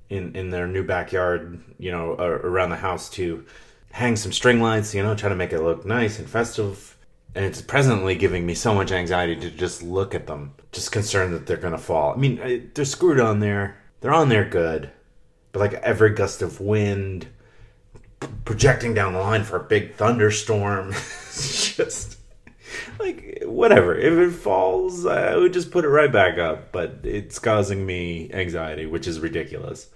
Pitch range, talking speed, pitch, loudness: 90-120 Hz, 185 wpm, 100 Hz, -22 LUFS